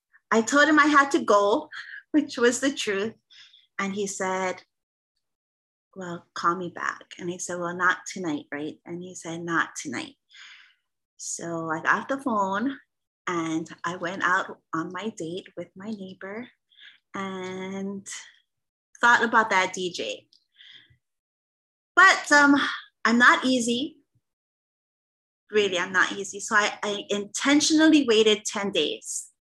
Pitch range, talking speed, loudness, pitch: 180-275 Hz, 135 wpm, -23 LUFS, 205 Hz